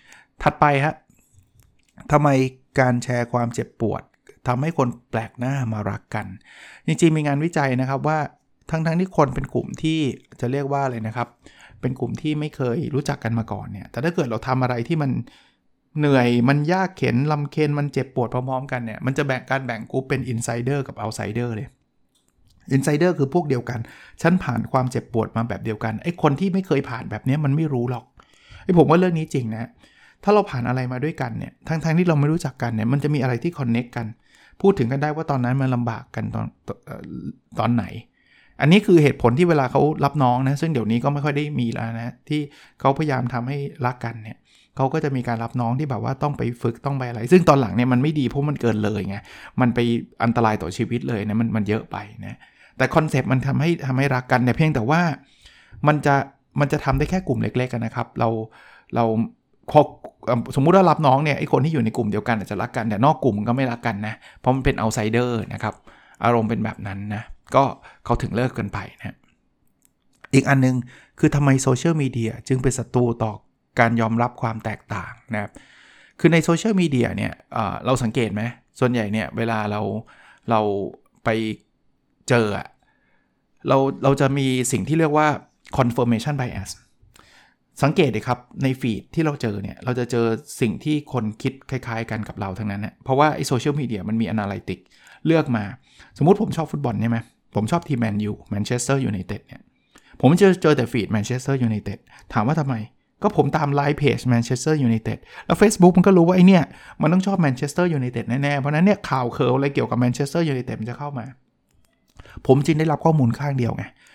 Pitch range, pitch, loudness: 115-145 Hz, 130 Hz, -21 LUFS